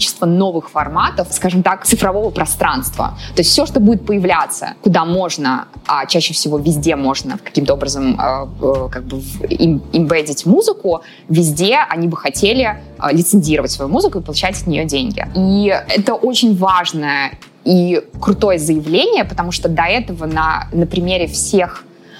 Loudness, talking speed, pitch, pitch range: -15 LUFS, 140 wpm, 170 Hz, 155-190 Hz